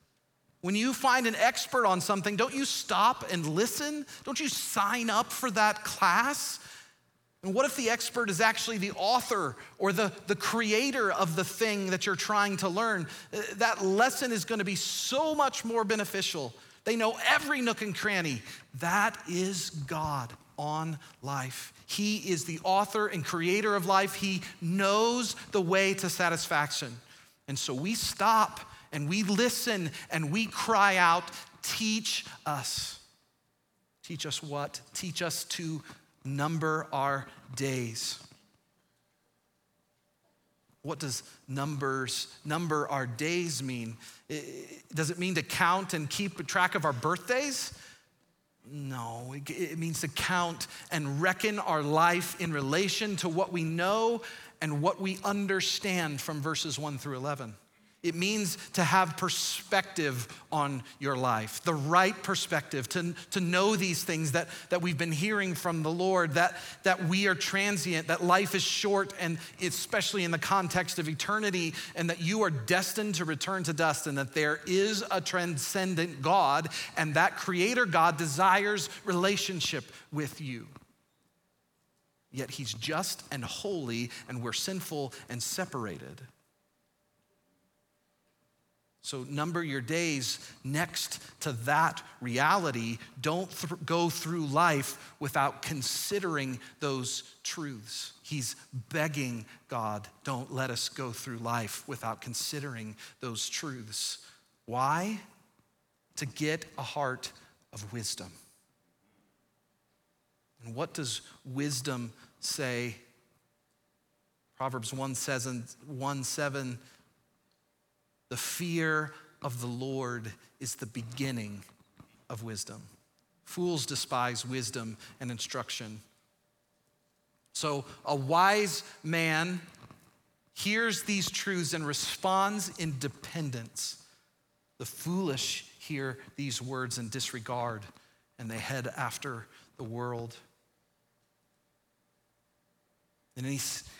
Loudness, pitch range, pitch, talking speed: -31 LUFS, 135-195 Hz, 165 Hz, 130 wpm